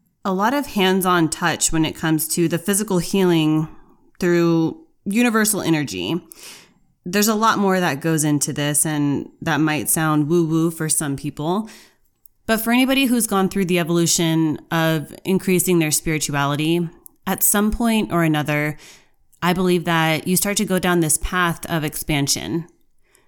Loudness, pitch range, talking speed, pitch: -19 LUFS, 155-190 Hz, 160 wpm, 170 Hz